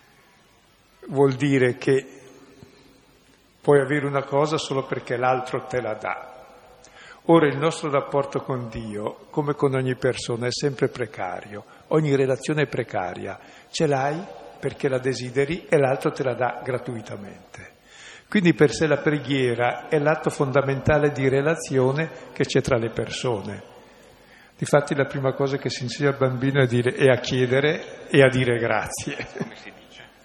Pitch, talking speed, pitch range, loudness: 135 Hz, 150 wpm, 125-145 Hz, -23 LUFS